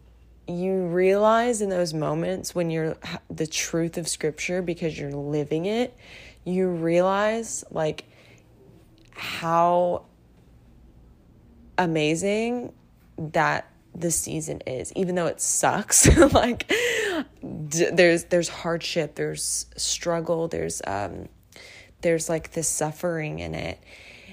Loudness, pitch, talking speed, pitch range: -24 LUFS, 165 Hz, 100 wpm, 115-180 Hz